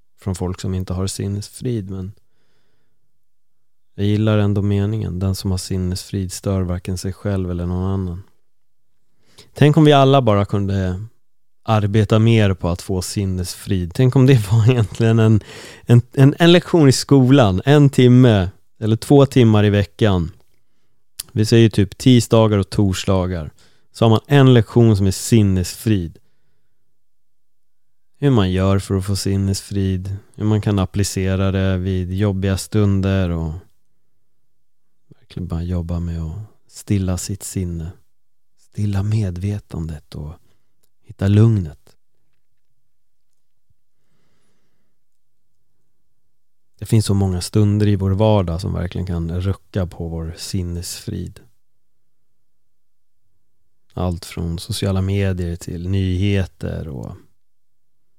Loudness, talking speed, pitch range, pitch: -17 LUFS, 120 wpm, 95-110 Hz, 100 Hz